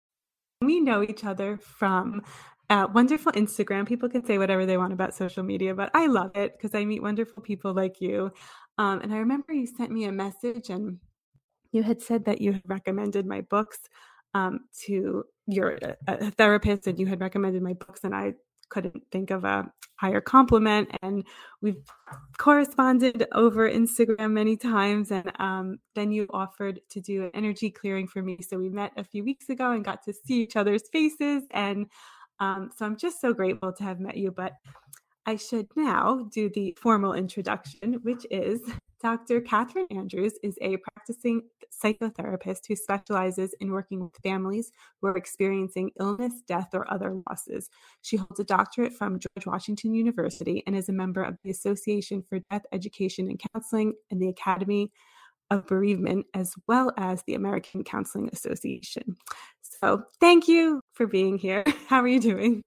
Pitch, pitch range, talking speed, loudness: 205 Hz, 190-230 Hz, 175 wpm, -27 LUFS